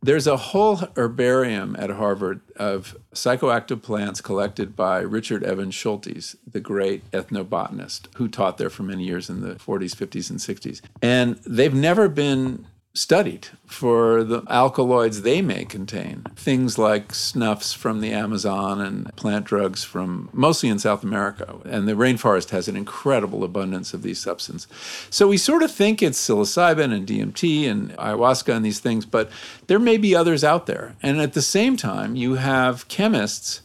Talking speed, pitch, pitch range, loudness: 165 wpm, 120 Hz, 105-150 Hz, -21 LUFS